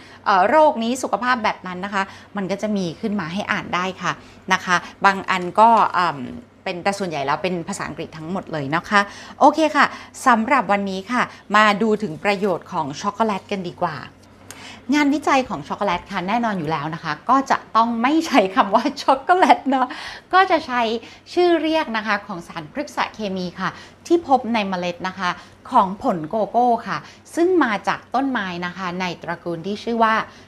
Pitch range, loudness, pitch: 180-245 Hz, -20 LUFS, 205 Hz